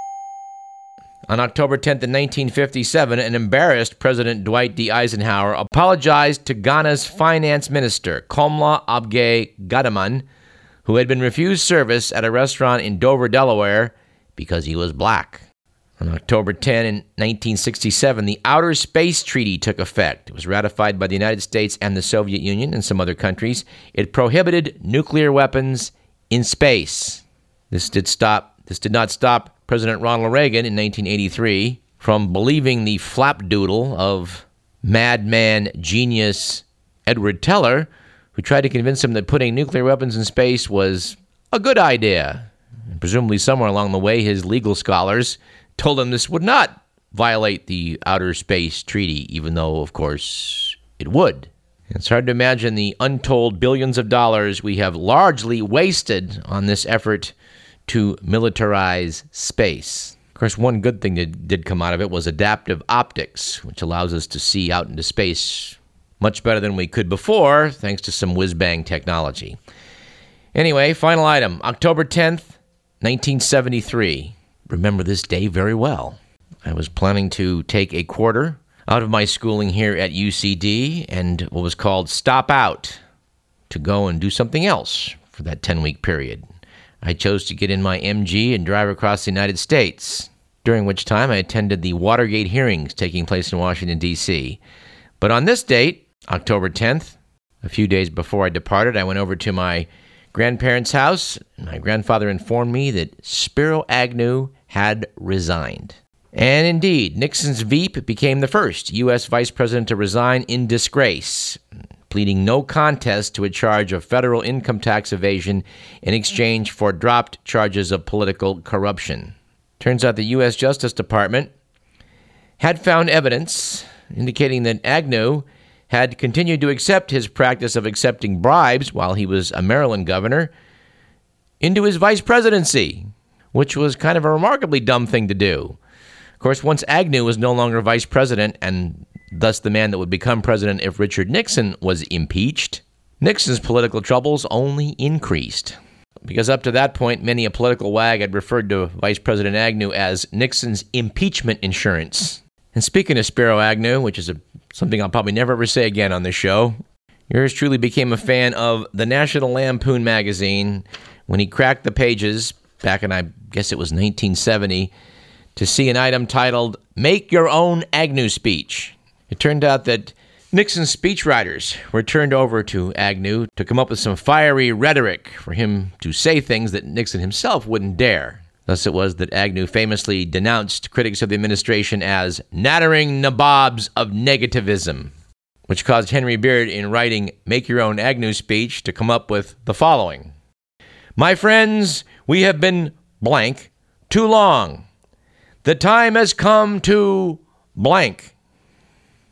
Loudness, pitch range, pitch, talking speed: -18 LUFS, 100-130 Hz, 110 Hz, 155 wpm